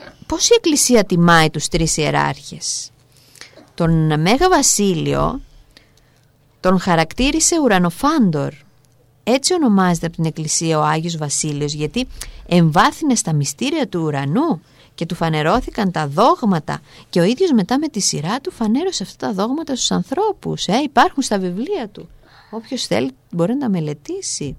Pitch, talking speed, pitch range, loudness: 185 Hz, 140 wpm, 155-255 Hz, -17 LUFS